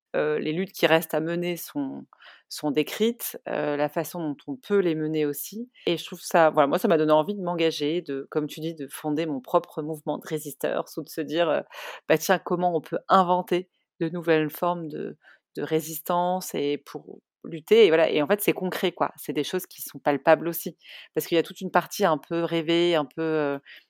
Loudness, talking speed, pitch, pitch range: -25 LUFS, 225 wpm, 165 Hz, 150-180 Hz